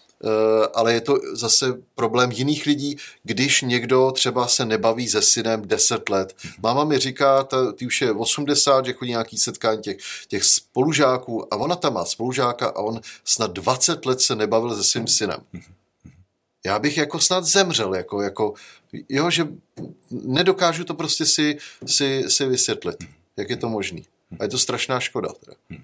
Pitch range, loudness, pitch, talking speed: 115-145 Hz, -20 LUFS, 130 Hz, 165 wpm